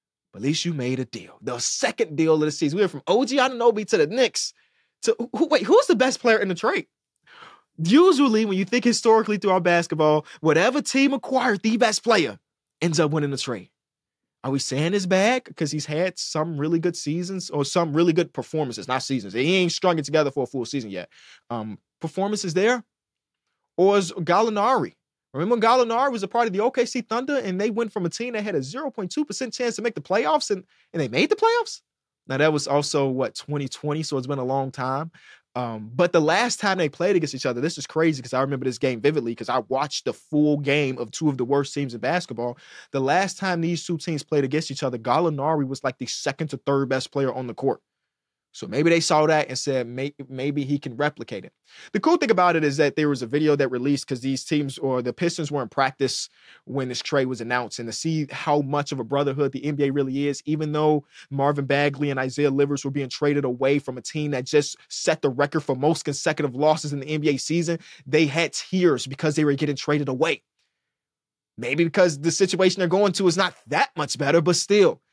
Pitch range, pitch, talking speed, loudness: 140-185 Hz, 155 Hz, 225 wpm, -23 LUFS